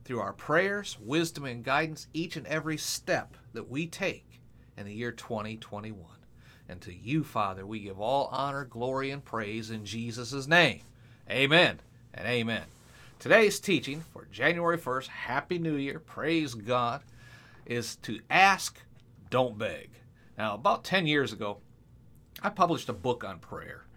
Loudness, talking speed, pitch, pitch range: -29 LUFS, 150 wpm, 125 Hz, 115-150 Hz